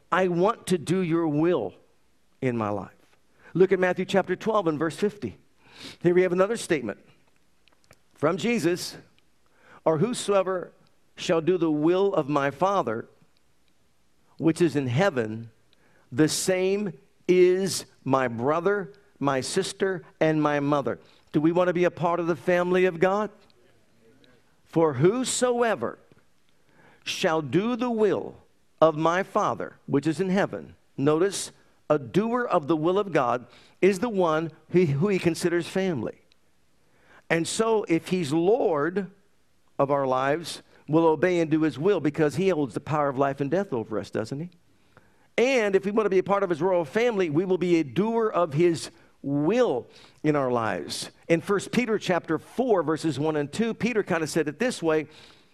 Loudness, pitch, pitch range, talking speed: -25 LUFS, 170 Hz, 150-190 Hz, 165 wpm